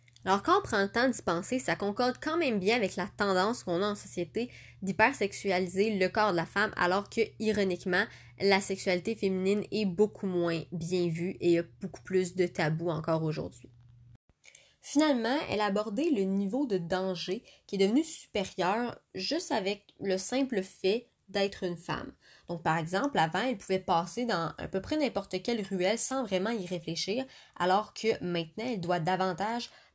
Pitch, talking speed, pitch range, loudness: 195 Hz, 175 wpm, 180-220 Hz, -31 LUFS